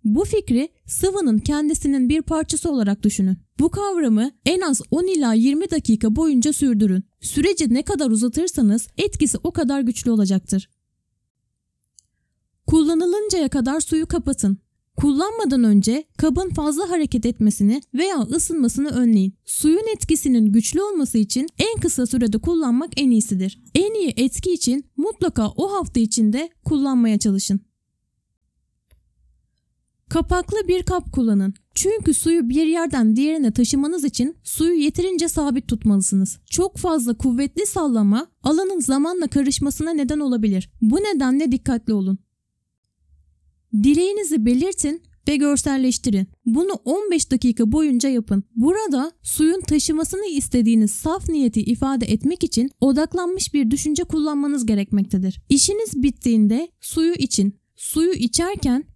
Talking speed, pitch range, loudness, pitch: 120 wpm, 230-325 Hz, -20 LUFS, 275 Hz